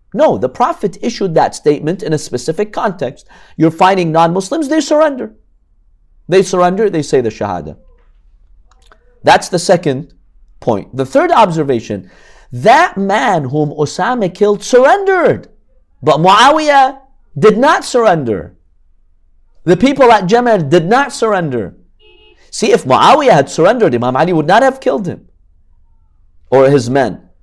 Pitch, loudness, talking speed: 160 Hz, -11 LUFS, 135 wpm